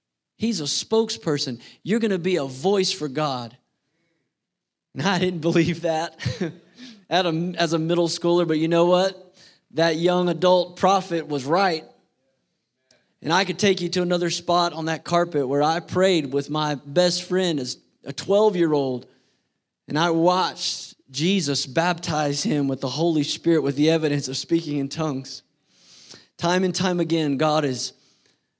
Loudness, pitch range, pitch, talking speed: -22 LUFS, 150-180 Hz, 170 Hz, 160 wpm